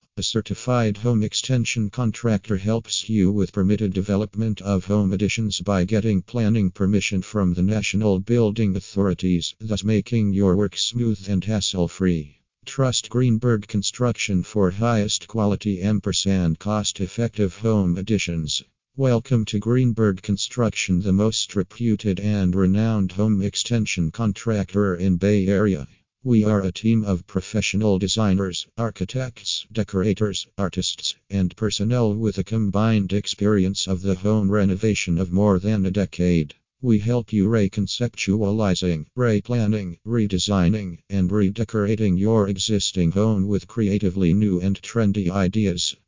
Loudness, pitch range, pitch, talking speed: -22 LUFS, 95-110 Hz, 100 Hz, 125 wpm